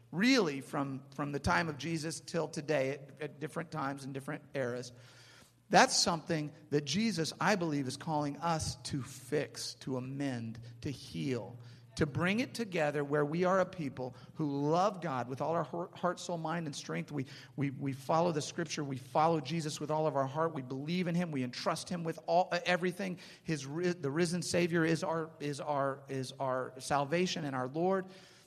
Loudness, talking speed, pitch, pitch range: -35 LUFS, 190 wpm, 150 Hz, 135-170 Hz